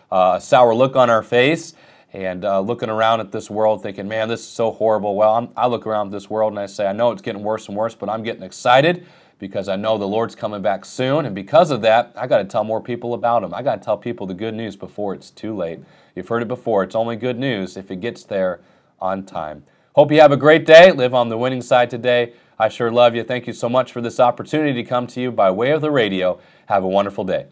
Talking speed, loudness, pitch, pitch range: 270 wpm, -18 LUFS, 115 Hz, 105-125 Hz